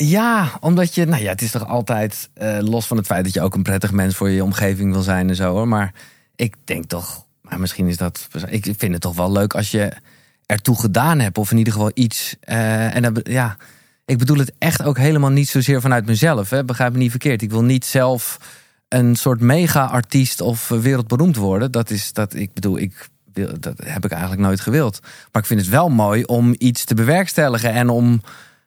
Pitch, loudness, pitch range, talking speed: 115 Hz, -18 LUFS, 100-130 Hz, 225 wpm